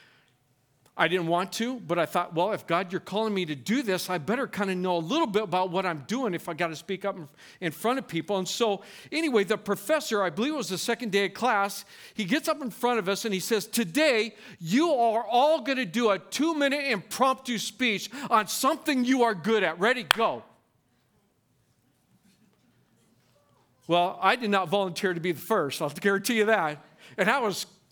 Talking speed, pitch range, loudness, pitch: 210 wpm, 180-235 Hz, -27 LUFS, 200 Hz